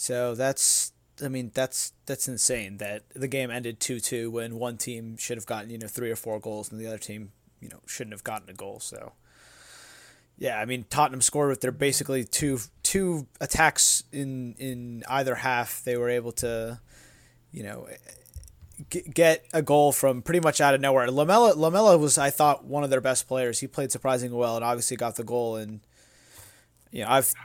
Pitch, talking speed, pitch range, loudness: 125 Hz, 195 wpm, 115-140 Hz, -25 LUFS